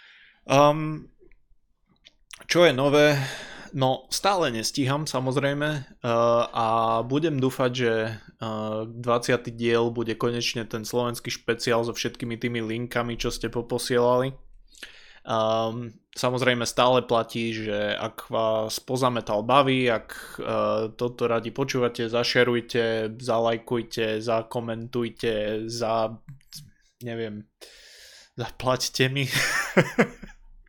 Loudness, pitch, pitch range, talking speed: -25 LUFS, 120 Hz, 115-130 Hz, 95 wpm